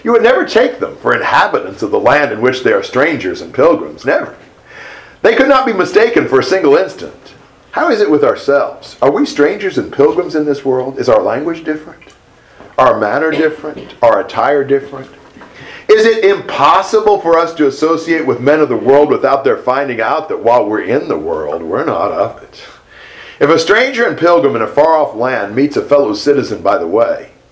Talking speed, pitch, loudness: 205 wpm, 195 Hz, -12 LUFS